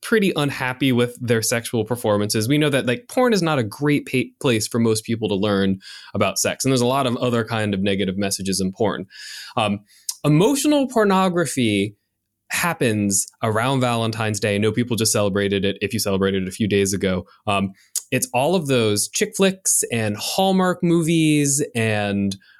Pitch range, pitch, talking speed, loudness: 105-140 Hz, 115 Hz, 180 wpm, -20 LUFS